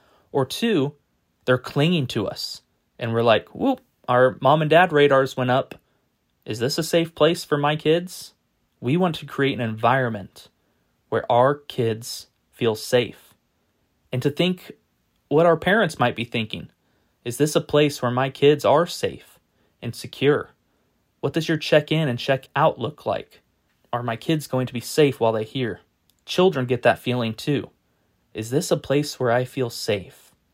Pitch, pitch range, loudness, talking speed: 130 Hz, 120-155 Hz, -22 LUFS, 175 wpm